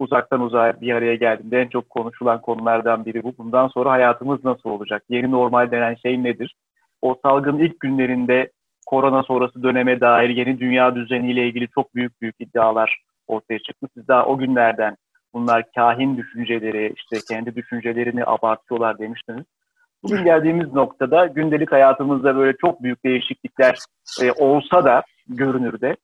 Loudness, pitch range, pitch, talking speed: -19 LUFS, 115-135 Hz, 125 Hz, 150 wpm